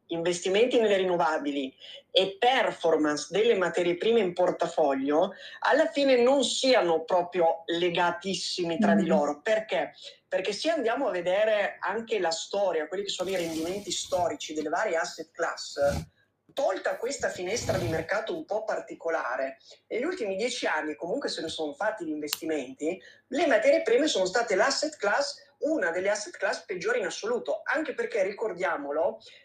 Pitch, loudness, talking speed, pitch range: 180 Hz, -27 LUFS, 150 wpm, 165-240 Hz